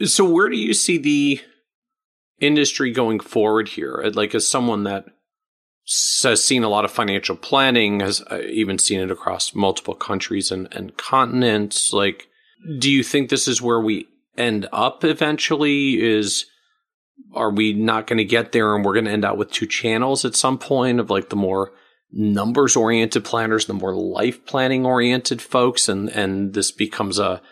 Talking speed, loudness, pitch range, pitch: 175 wpm, -19 LUFS, 105-140 Hz, 120 Hz